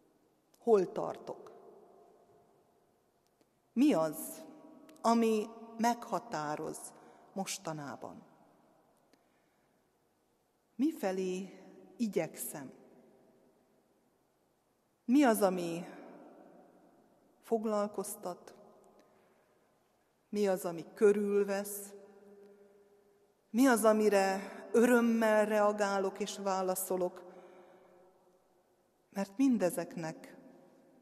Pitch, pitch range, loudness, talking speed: 200 Hz, 185-230 Hz, -33 LUFS, 50 wpm